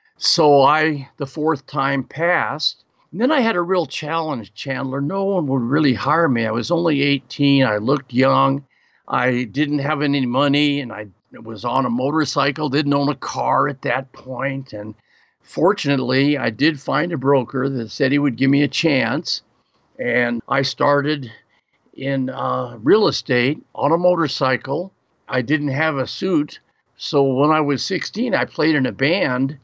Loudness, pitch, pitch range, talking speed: -19 LUFS, 140 Hz, 130-150 Hz, 170 wpm